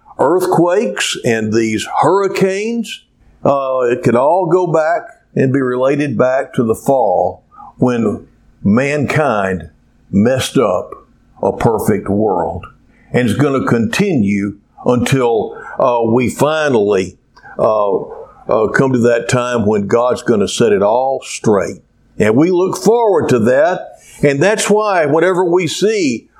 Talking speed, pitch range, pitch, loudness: 135 wpm, 120-180 Hz, 135 Hz, -14 LUFS